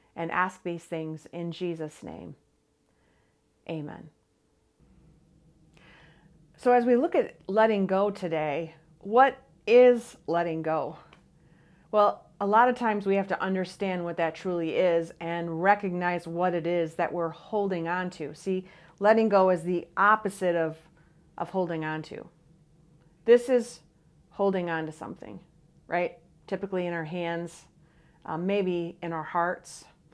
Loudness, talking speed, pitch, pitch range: -27 LUFS, 140 wpm, 170 Hz, 160-190 Hz